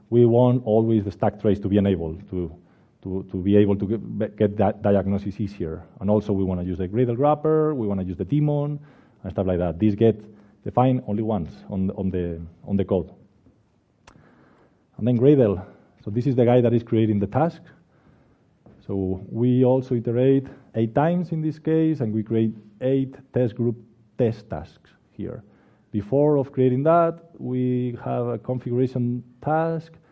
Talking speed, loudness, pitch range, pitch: 180 wpm, -23 LUFS, 100-130 Hz, 115 Hz